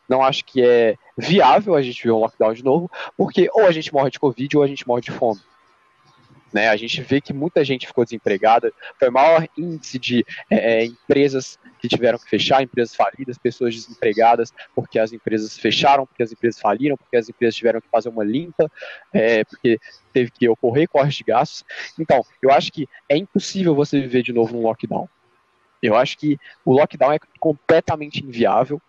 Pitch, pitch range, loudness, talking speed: 130 Hz, 115-145 Hz, -19 LUFS, 195 wpm